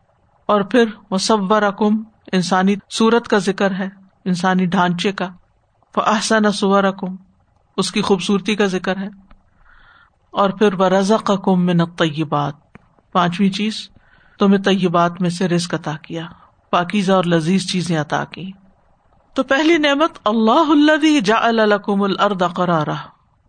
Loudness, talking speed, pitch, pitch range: -17 LUFS, 125 wpm, 195 Hz, 180-215 Hz